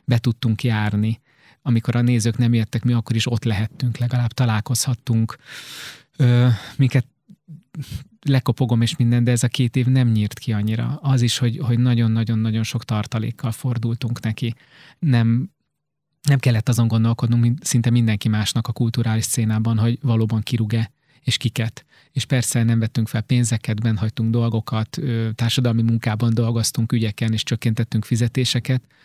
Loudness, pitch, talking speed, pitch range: -20 LUFS, 120 Hz, 145 wpm, 115-125 Hz